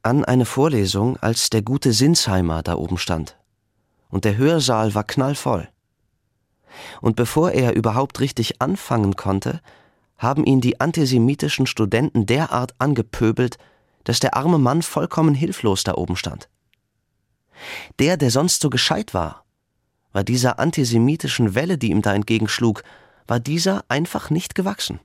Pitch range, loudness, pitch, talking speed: 110-140 Hz, -20 LUFS, 125 Hz, 135 wpm